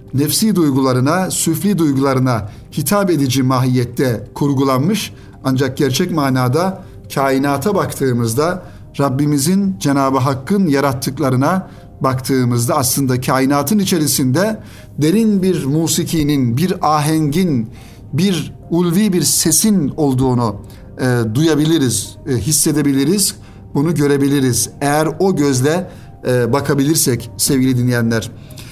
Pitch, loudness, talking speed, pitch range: 140 Hz, -15 LUFS, 90 wpm, 125-155 Hz